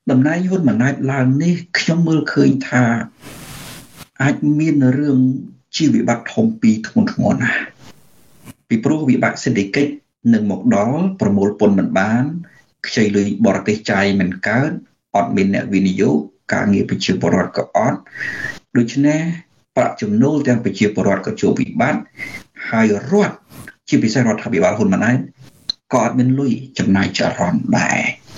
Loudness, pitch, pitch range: -17 LUFS, 135 Hz, 115-170 Hz